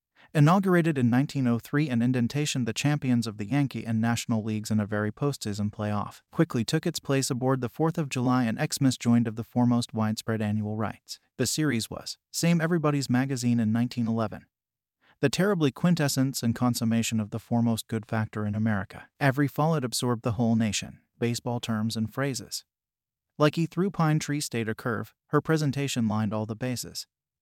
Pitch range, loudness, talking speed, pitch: 110-145 Hz, -27 LUFS, 175 wpm, 120 Hz